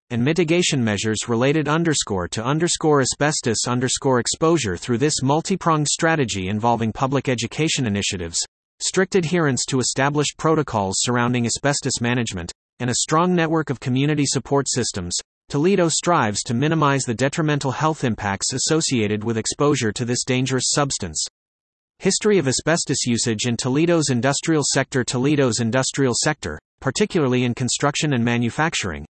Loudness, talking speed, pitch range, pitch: -20 LUFS, 135 wpm, 120-155 Hz, 135 Hz